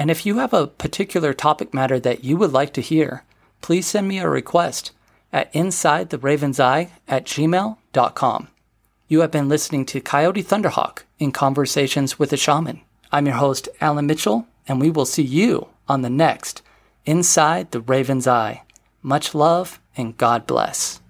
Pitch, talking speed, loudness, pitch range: 145 Hz, 170 wpm, -19 LUFS, 135-160 Hz